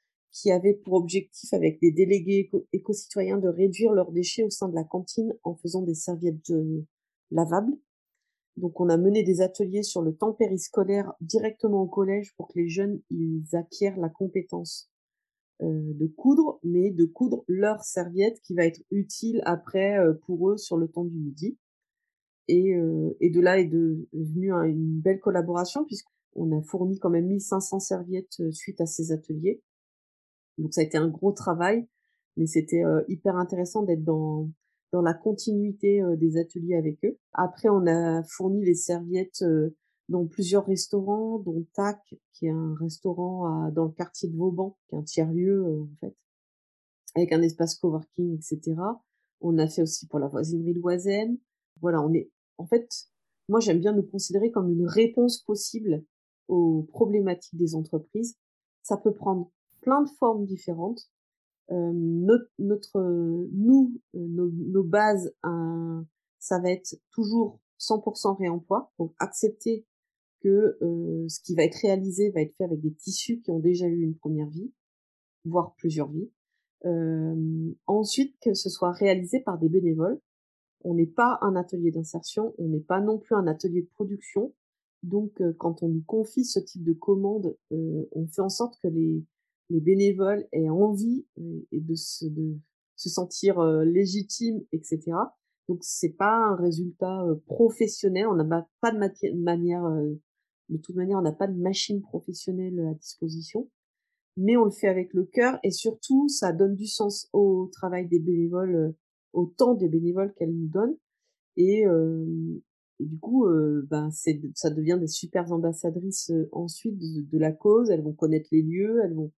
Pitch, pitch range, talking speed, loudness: 180 Hz, 165-205 Hz, 175 wpm, -26 LUFS